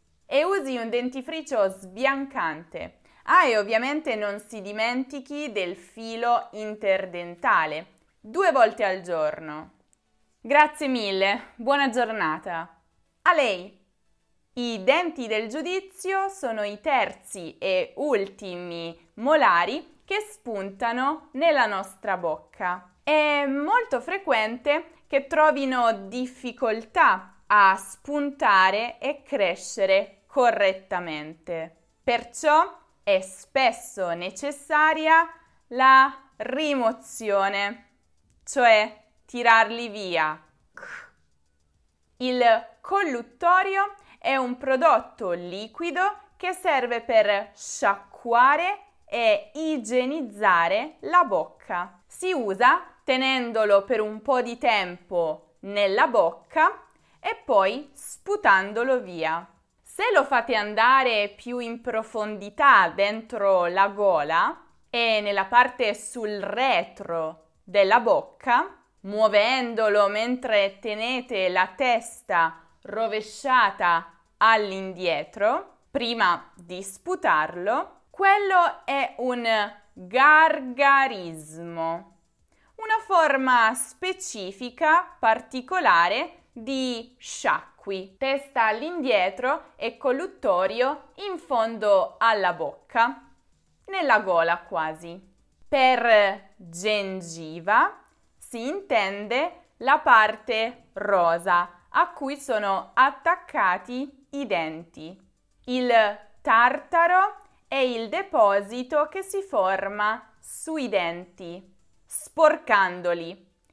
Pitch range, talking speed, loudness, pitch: 195-285 Hz, 85 wpm, -23 LUFS, 230 Hz